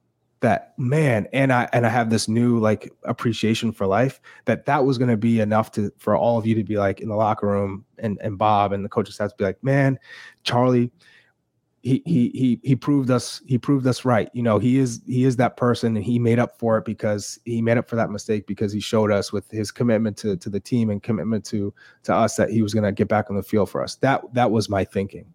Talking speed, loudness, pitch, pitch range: 255 wpm, -22 LUFS, 110 Hz, 105-125 Hz